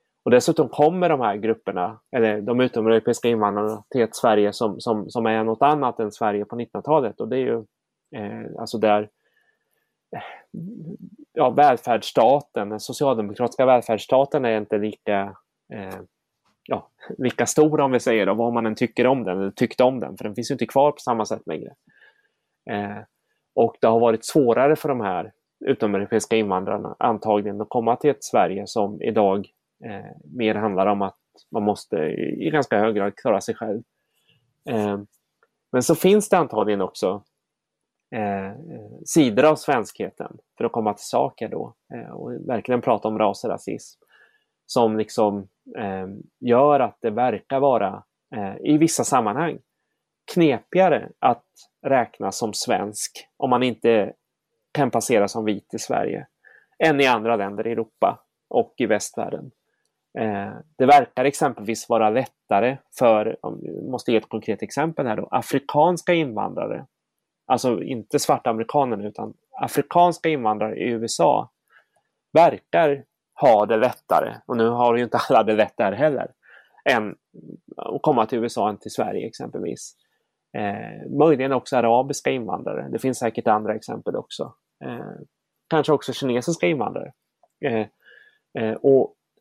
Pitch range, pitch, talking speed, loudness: 105-140 Hz, 115 Hz, 150 wpm, -22 LUFS